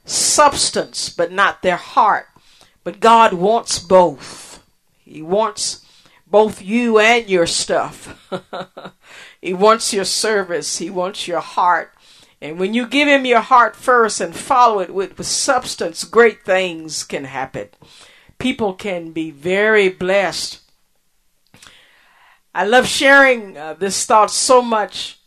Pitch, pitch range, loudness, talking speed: 200 Hz, 180-230 Hz, -15 LUFS, 130 wpm